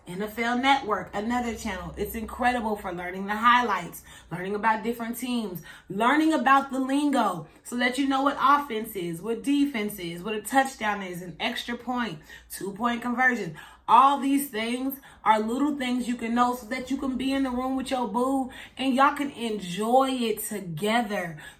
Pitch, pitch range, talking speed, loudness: 240 Hz, 210-265 Hz, 180 wpm, -26 LUFS